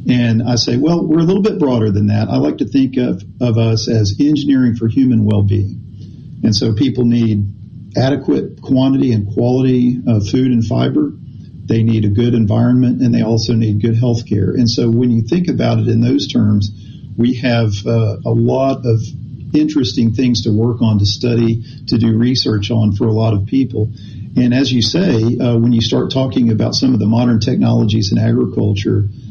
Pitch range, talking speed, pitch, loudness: 110-125 Hz, 200 wpm, 115 Hz, -14 LUFS